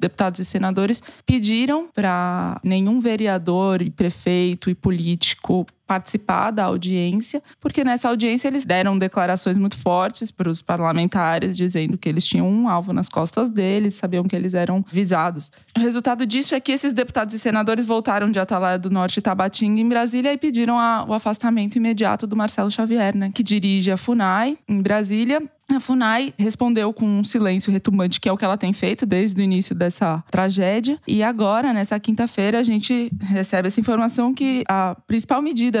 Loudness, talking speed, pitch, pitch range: -20 LUFS, 175 wpm, 205 Hz, 185-235 Hz